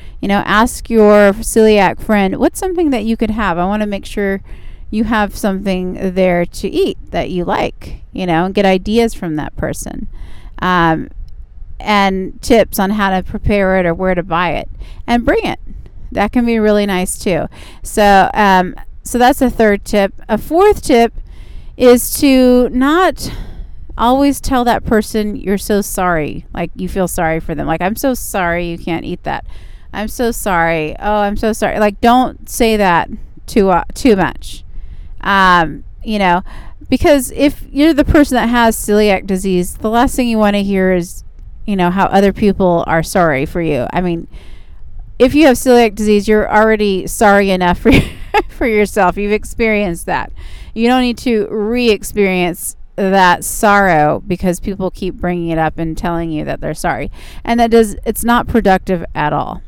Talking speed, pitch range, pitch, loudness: 180 wpm, 180-230 Hz, 200 Hz, -13 LUFS